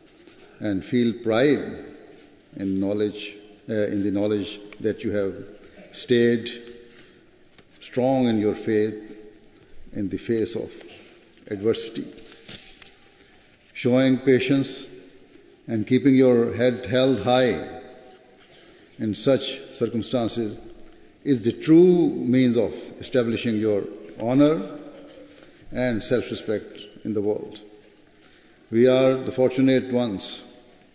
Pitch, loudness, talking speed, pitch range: 120 Hz, -23 LUFS, 100 wpm, 105-130 Hz